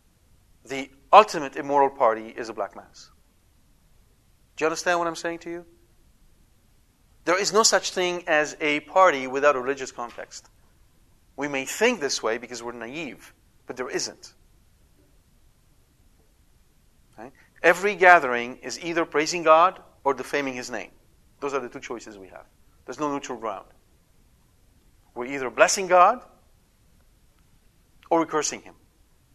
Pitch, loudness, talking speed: 130 Hz, -23 LUFS, 140 wpm